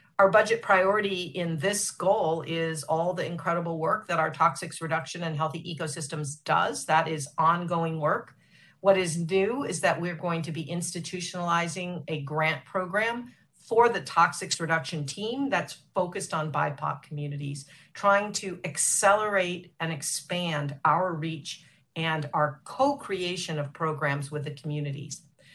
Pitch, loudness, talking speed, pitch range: 165 Hz, -27 LUFS, 145 wpm, 160-185 Hz